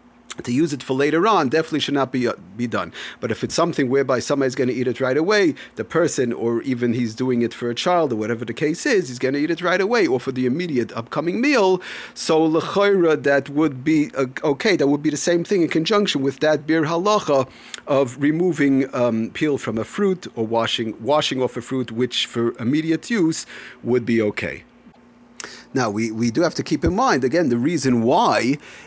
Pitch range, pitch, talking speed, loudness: 120-160 Hz, 135 Hz, 220 wpm, -20 LUFS